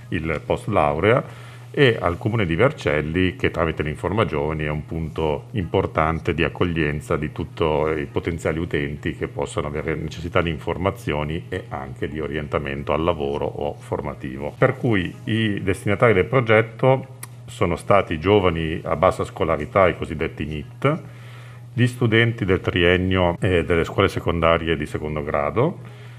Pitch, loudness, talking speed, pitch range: 90 Hz, -22 LUFS, 140 wpm, 80-115 Hz